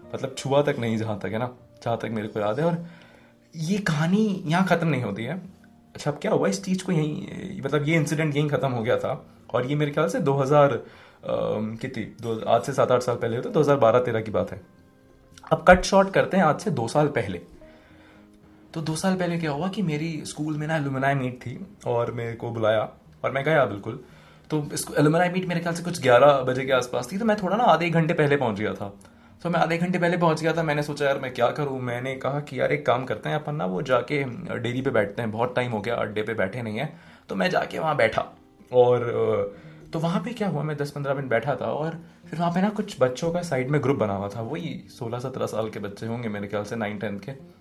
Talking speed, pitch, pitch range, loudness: 255 wpm, 145 Hz, 115-165 Hz, -25 LUFS